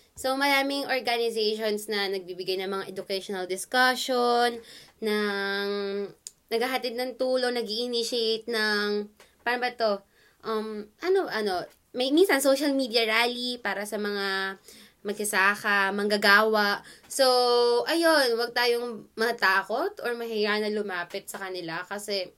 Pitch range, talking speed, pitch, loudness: 200-245 Hz, 120 wpm, 220 Hz, -26 LUFS